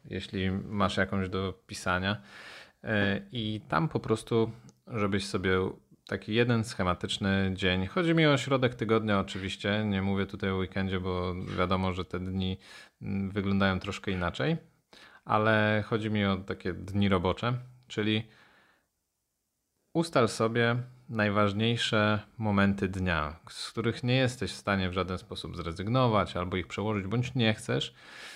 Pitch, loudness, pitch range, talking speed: 100 Hz, -30 LUFS, 95-115 Hz, 135 wpm